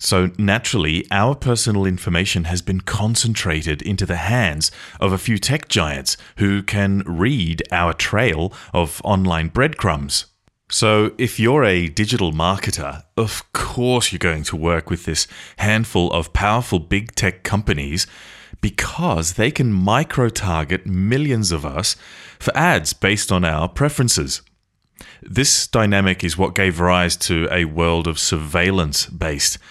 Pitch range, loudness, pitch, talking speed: 85-110 Hz, -19 LUFS, 95 Hz, 140 wpm